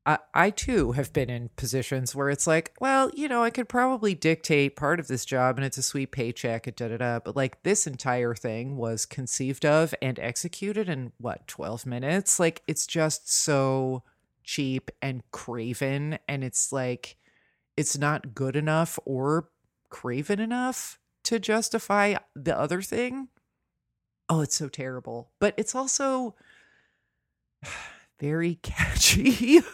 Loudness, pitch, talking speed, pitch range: -27 LUFS, 145 Hz, 150 wpm, 130-190 Hz